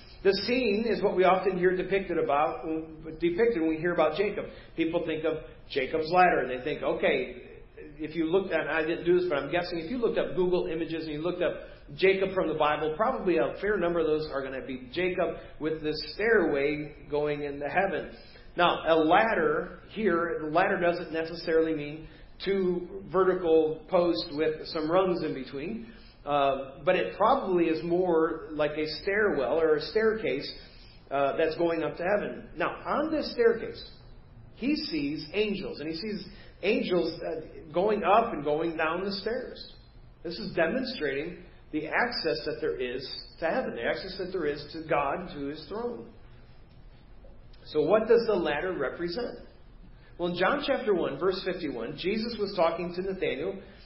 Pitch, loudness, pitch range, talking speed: 170 Hz, -28 LUFS, 155-190 Hz, 175 wpm